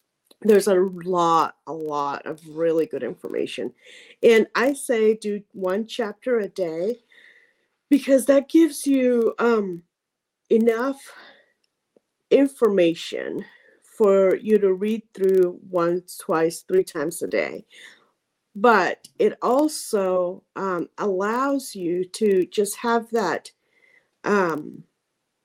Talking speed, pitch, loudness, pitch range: 110 wpm, 220 Hz, -22 LUFS, 185-275 Hz